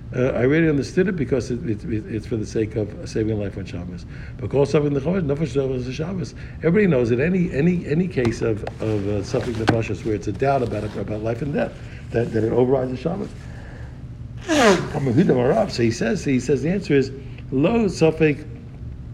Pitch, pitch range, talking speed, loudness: 125 Hz, 110-145 Hz, 190 wpm, -21 LUFS